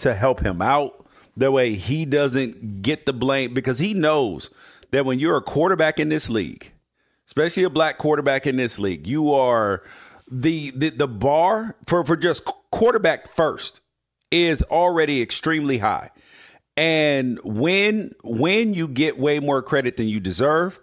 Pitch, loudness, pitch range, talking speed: 145 Hz, -21 LUFS, 130-160 Hz, 160 wpm